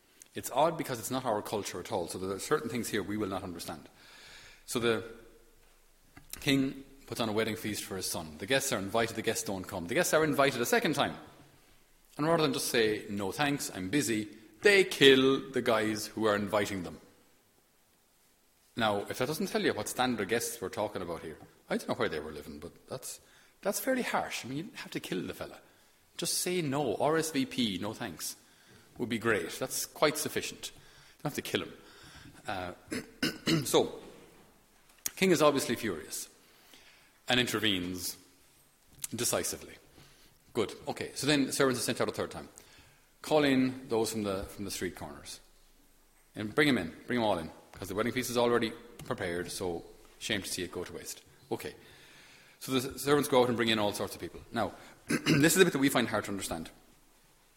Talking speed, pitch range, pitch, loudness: 200 wpm, 100-140 Hz, 115 Hz, -31 LUFS